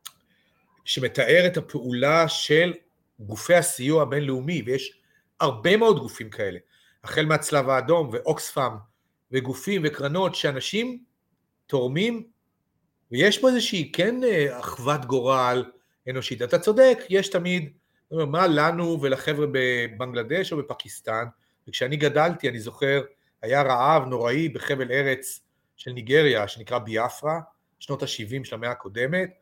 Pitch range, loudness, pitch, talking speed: 130-170 Hz, -23 LUFS, 145 Hz, 110 wpm